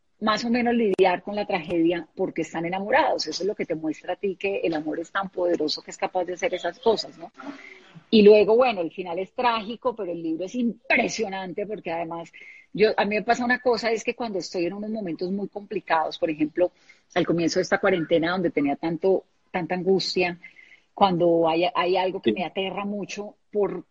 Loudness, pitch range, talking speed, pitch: -24 LUFS, 170-210 Hz, 210 wpm, 185 Hz